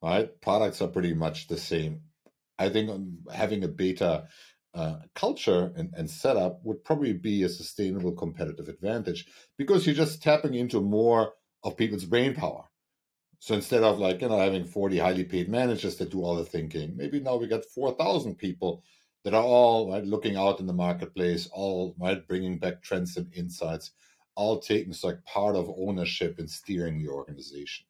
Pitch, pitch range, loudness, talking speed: 95 Hz, 85-110 Hz, -28 LUFS, 180 wpm